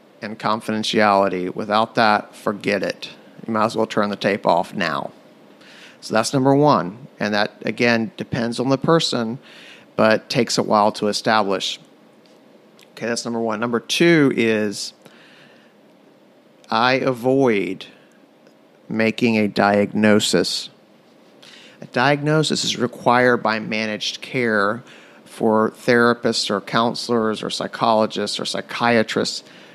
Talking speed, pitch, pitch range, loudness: 120 wpm, 110 Hz, 105-120 Hz, -19 LUFS